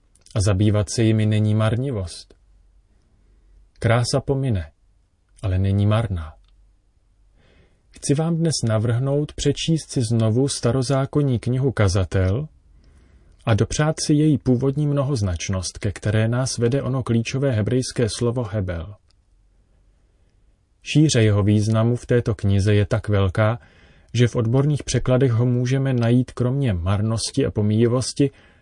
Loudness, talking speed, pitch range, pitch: -21 LUFS, 115 wpm, 95-125 Hz, 110 Hz